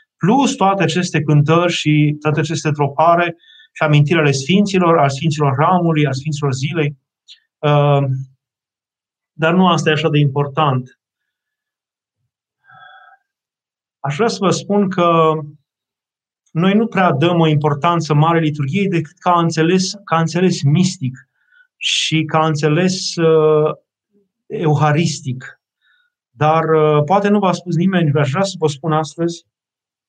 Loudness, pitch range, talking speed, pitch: -15 LUFS, 150-180 Hz, 120 wpm, 160 Hz